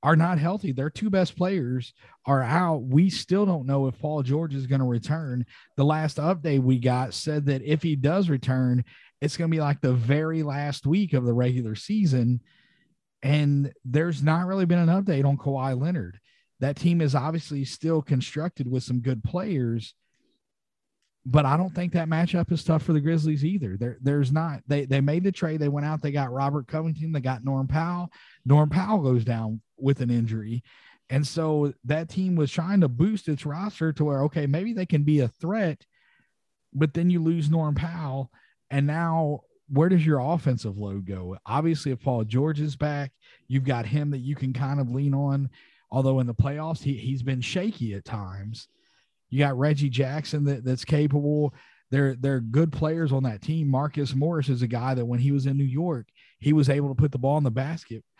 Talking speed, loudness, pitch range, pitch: 205 wpm, -25 LUFS, 130-160 Hz, 145 Hz